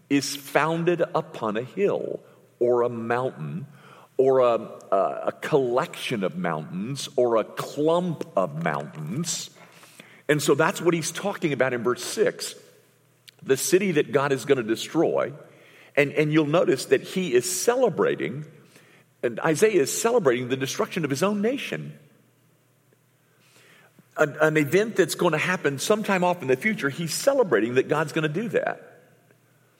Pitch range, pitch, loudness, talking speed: 140-185 Hz, 155 Hz, -24 LUFS, 150 wpm